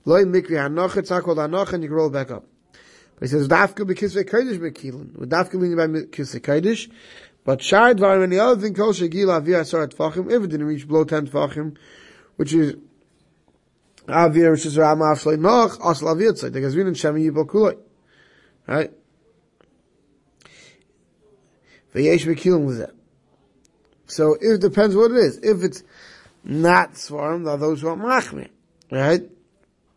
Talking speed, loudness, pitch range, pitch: 165 wpm, -19 LUFS, 155-195 Hz, 165 Hz